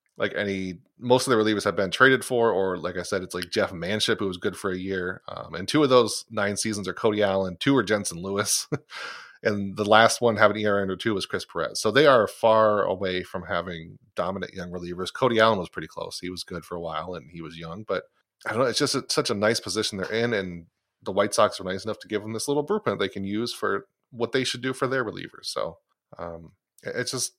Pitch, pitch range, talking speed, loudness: 105 Hz, 90-115 Hz, 250 wpm, -25 LUFS